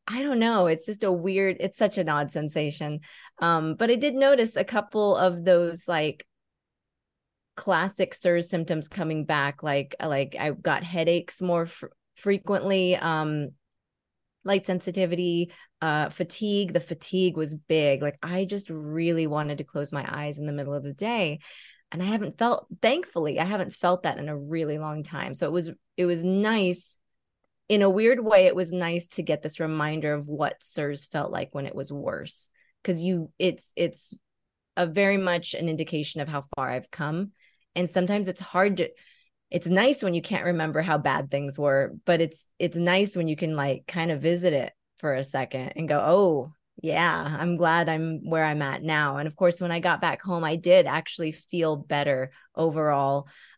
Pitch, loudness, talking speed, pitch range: 170 Hz, -26 LUFS, 190 wpm, 150-185 Hz